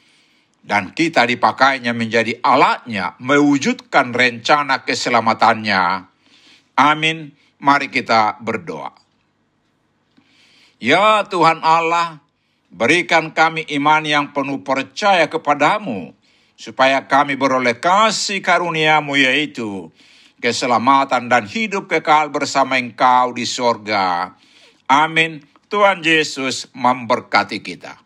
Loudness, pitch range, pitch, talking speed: -16 LUFS, 125-160 Hz, 140 Hz, 90 wpm